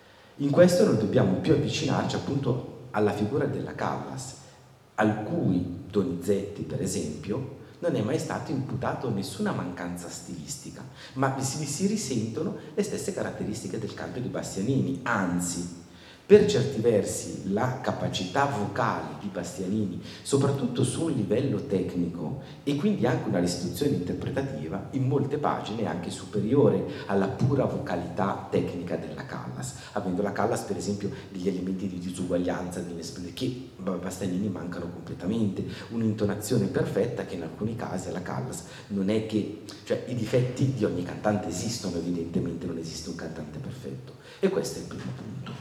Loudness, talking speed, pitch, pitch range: -29 LUFS, 145 wpm, 100 Hz, 85-125 Hz